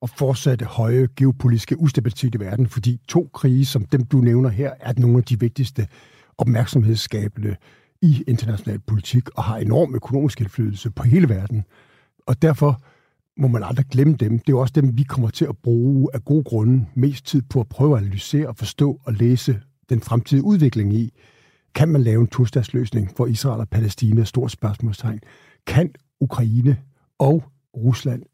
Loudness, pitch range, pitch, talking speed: -20 LUFS, 115-140 Hz, 125 Hz, 175 wpm